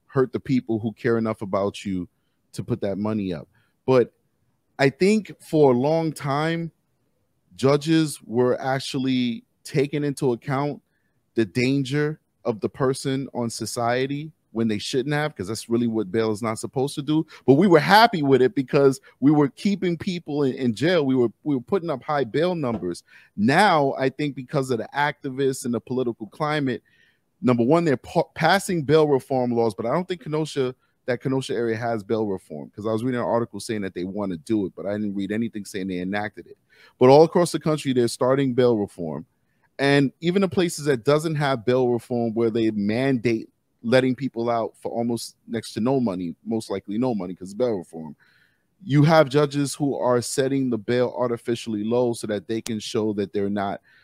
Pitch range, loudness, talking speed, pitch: 115-145 Hz, -23 LUFS, 195 wpm, 125 Hz